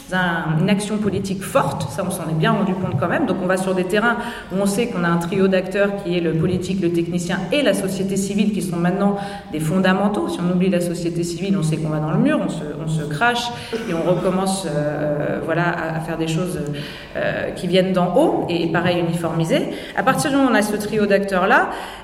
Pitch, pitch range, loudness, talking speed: 185 Hz, 170-200 Hz, -20 LUFS, 235 wpm